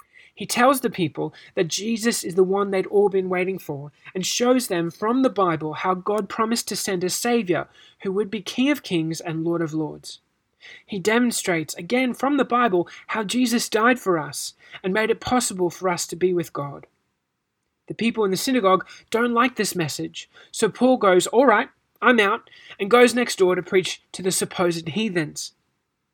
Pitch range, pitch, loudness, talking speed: 175-235 Hz, 195 Hz, -22 LUFS, 190 wpm